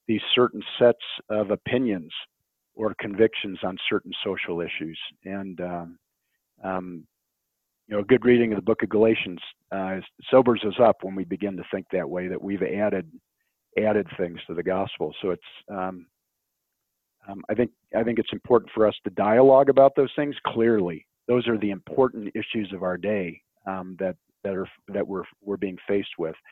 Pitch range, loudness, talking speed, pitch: 95-115 Hz, -25 LUFS, 180 wpm, 100 Hz